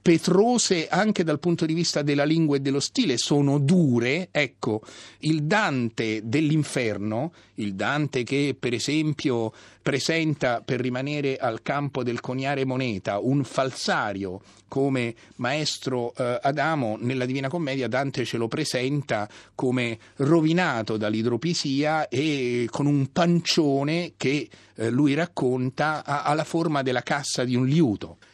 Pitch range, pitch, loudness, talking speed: 120-155 Hz, 140 Hz, -25 LUFS, 125 wpm